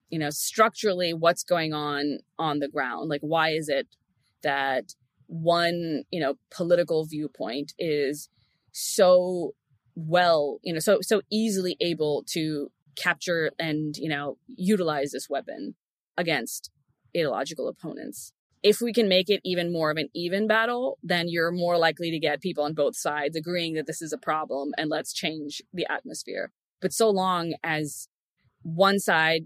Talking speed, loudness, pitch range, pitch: 155 wpm, -26 LUFS, 150-180 Hz, 165 Hz